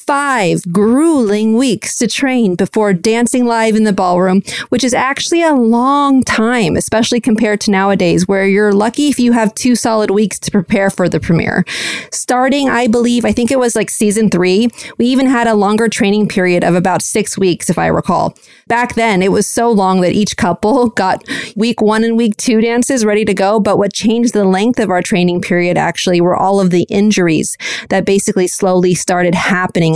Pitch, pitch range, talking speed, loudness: 210 Hz, 190-235 Hz, 195 wpm, -12 LUFS